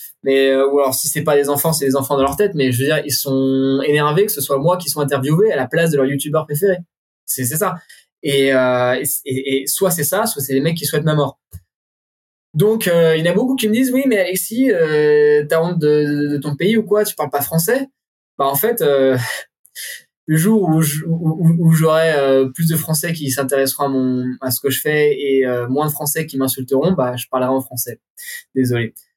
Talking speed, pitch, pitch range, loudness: 235 wpm, 150 Hz, 135-170 Hz, -16 LUFS